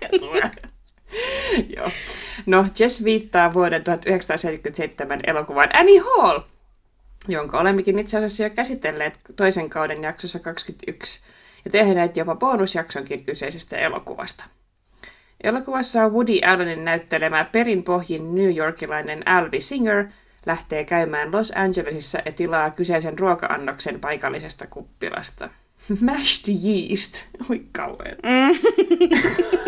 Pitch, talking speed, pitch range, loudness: 190 Hz, 100 wpm, 165-230 Hz, -21 LUFS